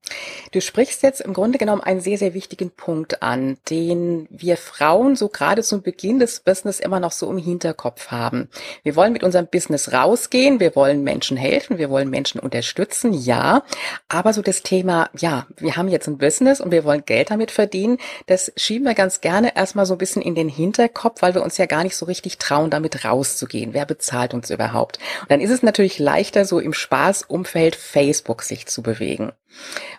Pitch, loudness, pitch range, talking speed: 180 Hz, -19 LUFS, 155-205 Hz, 195 wpm